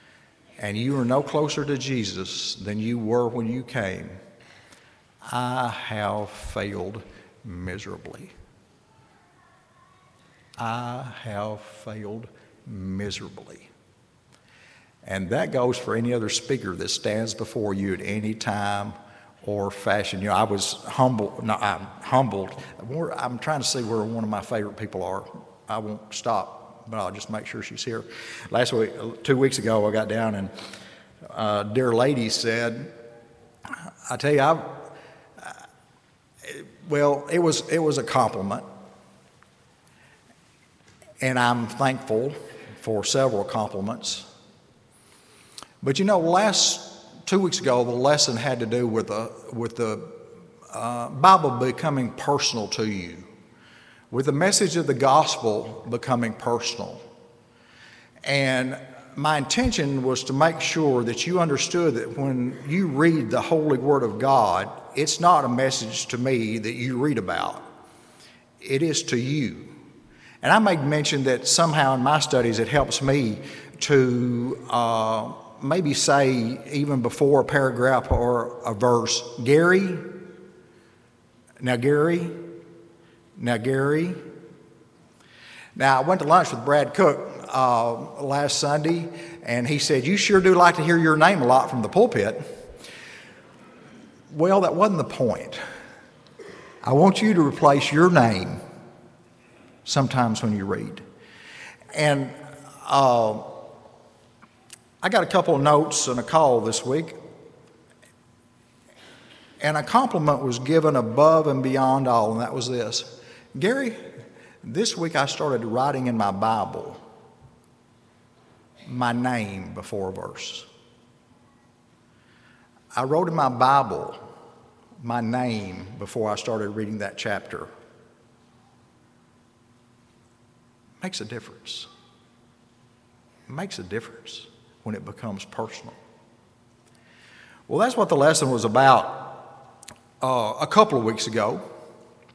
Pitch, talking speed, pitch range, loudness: 125 Hz, 130 wpm, 110-145 Hz, -23 LUFS